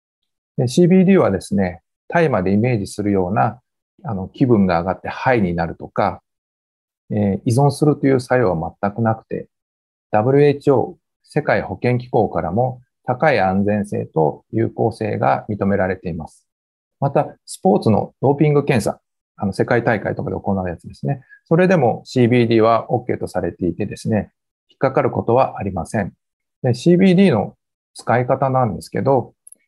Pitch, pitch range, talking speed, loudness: 105 Hz, 90-130 Hz, 315 characters per minute, -18 LUFS